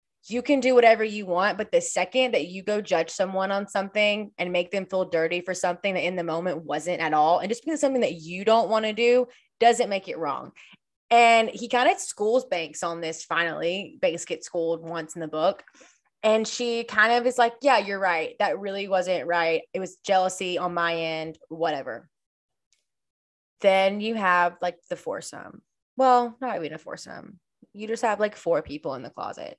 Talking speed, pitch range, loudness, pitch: 205 wpm, 175-230 Hz, -24 LUFS, 195 Hz